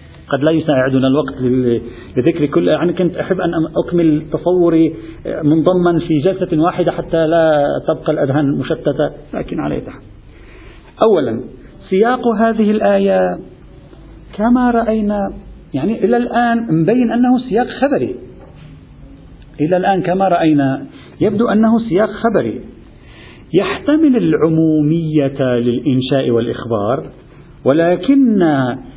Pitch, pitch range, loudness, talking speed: 165 Hz, 145-210 Hz, -15 LUFS, 100 wpm